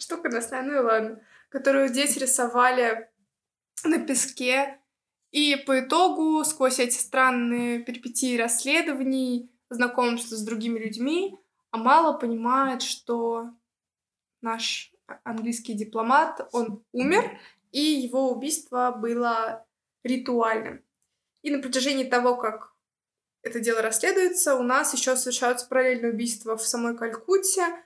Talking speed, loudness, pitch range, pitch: 110 wpm, -24 LUFS, 235-275 Hz, 250 Hz